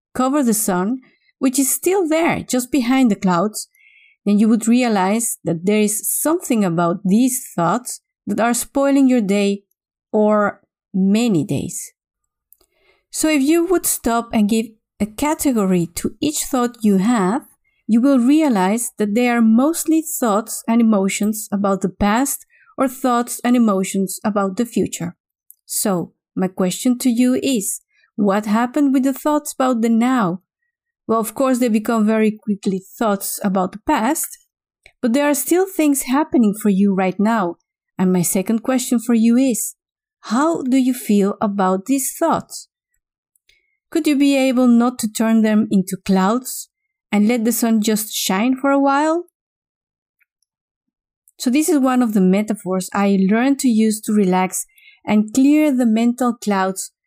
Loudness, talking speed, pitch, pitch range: -17 LUFS, 160 wpm, 235 Hz, 205-275 Hz